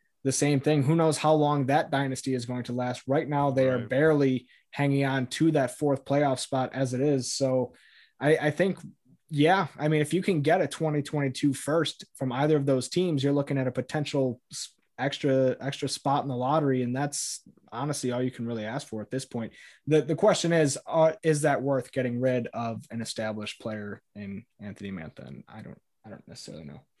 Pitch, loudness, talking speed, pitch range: 140 Hz, -27 LUFS, 210 wpm, 125-150 Hz